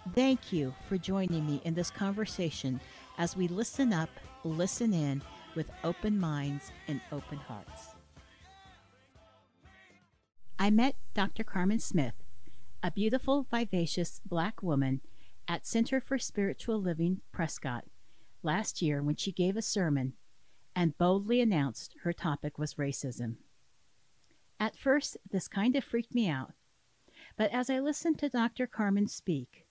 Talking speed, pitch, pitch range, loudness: 135 wpm, 175 Hz, 140-215 Hz, -33 LUFS